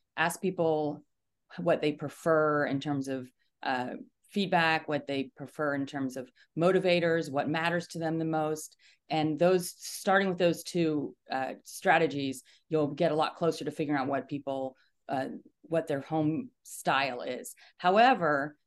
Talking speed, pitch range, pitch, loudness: 155 wpm, 140-170 Hz, 155 Hz, -30 LUFS